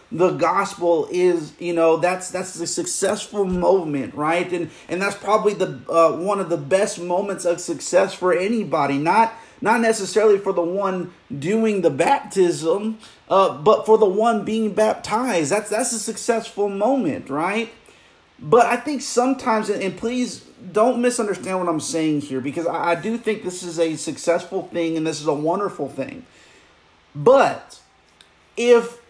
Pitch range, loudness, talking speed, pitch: 170-225 Hz, -20 LUFS, 160 wpm, 195 Hz